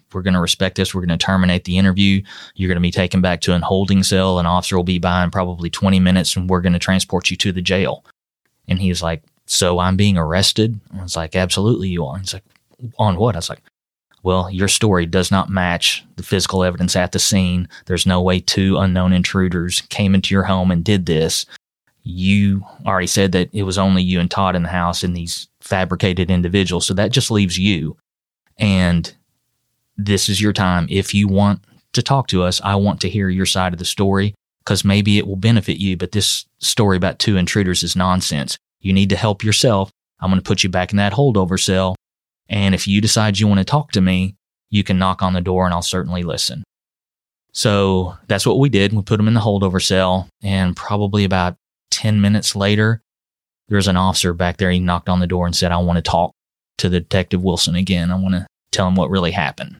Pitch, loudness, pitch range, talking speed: 95 Hz, -17 LUFS, 90-100 Hz, 225 wpm